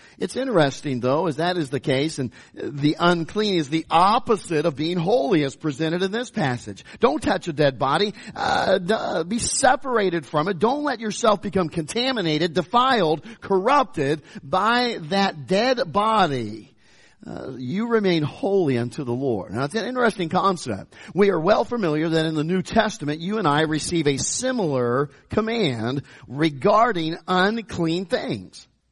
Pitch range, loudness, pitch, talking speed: 150-215 Hz, -22 LUFS, 175 Hz, 155 wpm